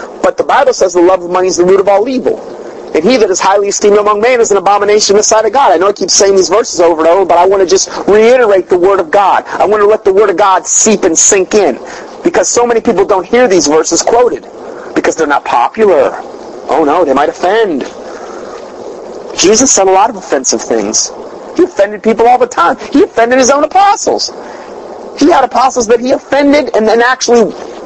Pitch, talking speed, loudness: 240 Hz, 230 wpm, -8 LUFS